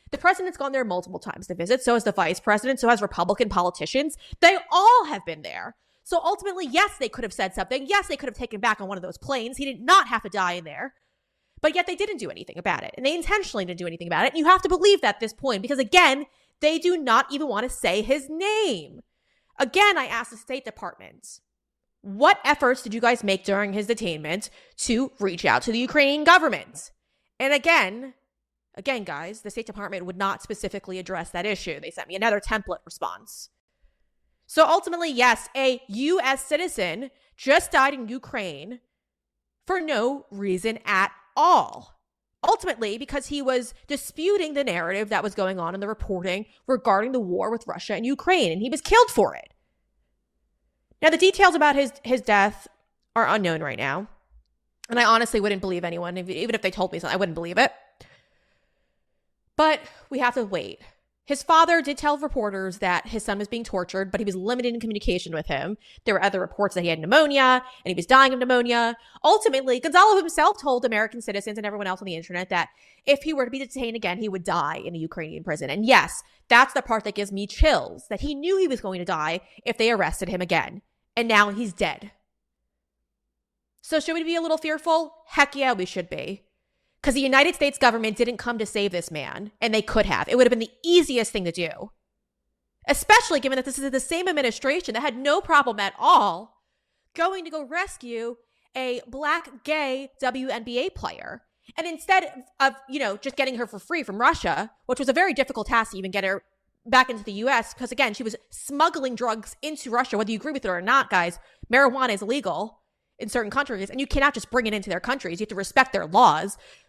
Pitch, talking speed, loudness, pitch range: 245 Hz, 210 wpm, -23 LUFS, 200-285 Hz